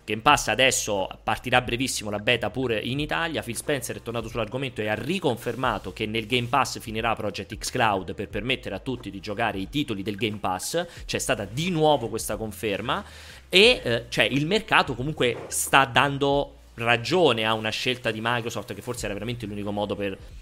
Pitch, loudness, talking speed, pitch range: 115 Hz, -25 LUFS, 190 wpm, 105-130 Hz